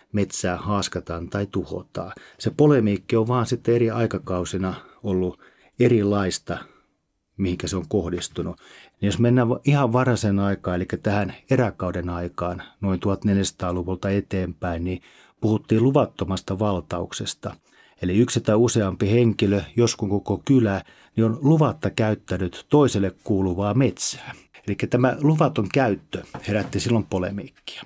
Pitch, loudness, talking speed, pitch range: 100 Hz, -23 LUFS, 120 wpm, 95-120 Hz